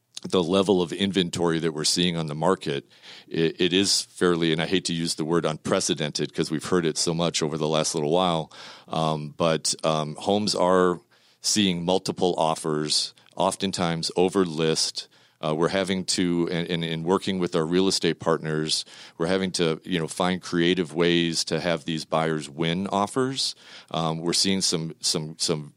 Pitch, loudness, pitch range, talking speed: 85 Hz, -24 LUFS, 80-95 Hz, 180 wpm